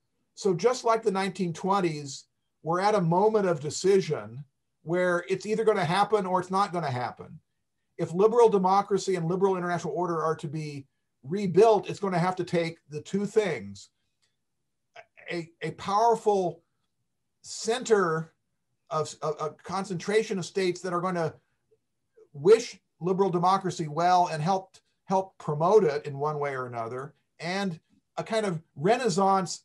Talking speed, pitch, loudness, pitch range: 155 wpm, 180 Hz, -27 LUFS, 160-200 Hz